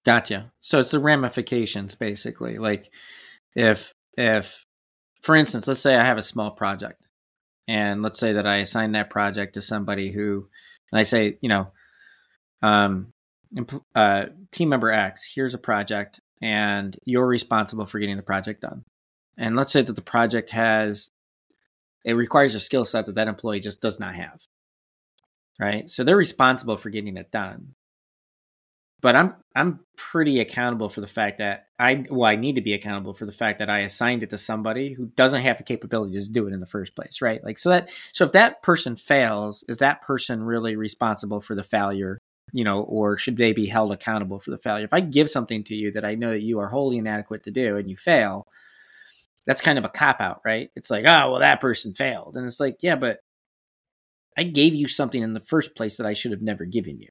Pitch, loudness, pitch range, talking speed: 110 Hz, -22 LUFS, 105-125 Hz, 205 wpm